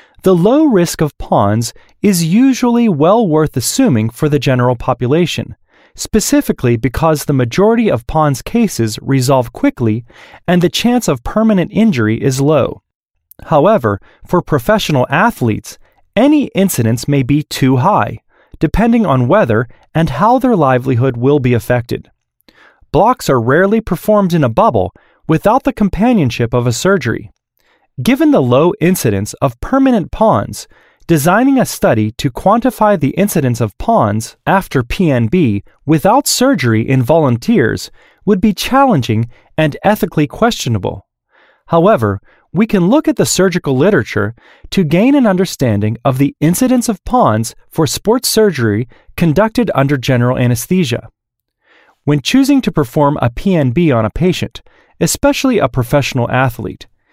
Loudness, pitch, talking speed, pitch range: -13 LUFS, 155 Hz, 135 wpm, 125-210 Hz